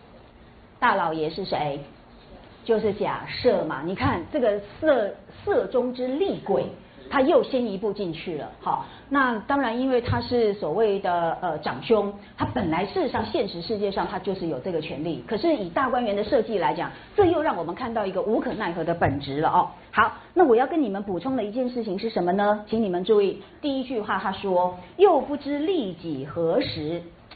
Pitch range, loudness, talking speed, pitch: 180-265 Hz, -25 LUFS, 275 characters per minute, 210 Hz